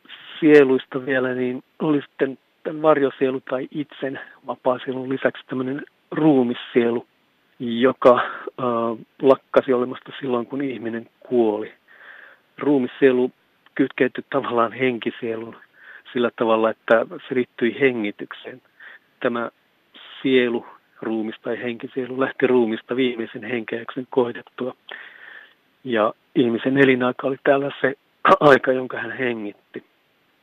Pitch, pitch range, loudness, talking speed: 130 Hz, 120-135 Hz, -21 LUFS, 100 wpm